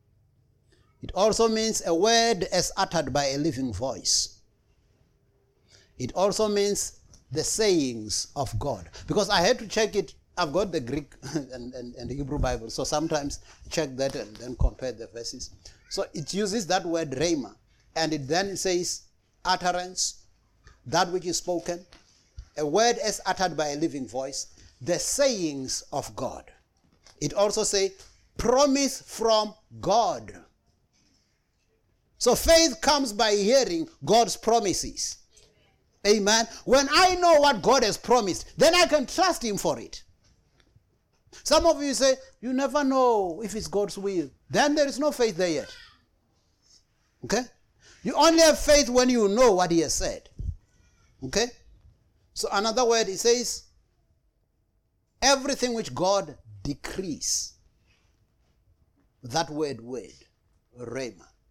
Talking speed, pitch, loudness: 140 wpm, 180 Hz, -25 LUFS